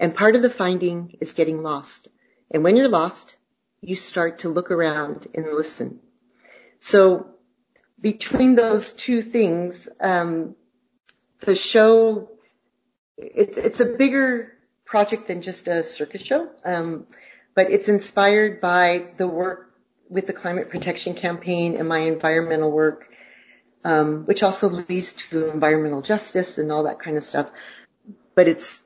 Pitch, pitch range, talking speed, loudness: 180 Hz, 165-215 Hz, 140 wpm, -21 LUFS